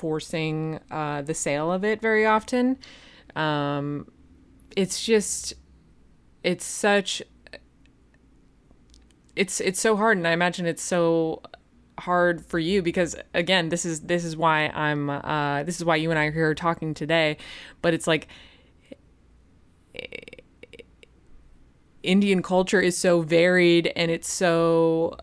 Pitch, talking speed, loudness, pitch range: 165 Hz, 130 wpm, -24 LUFS, 150-180 Hz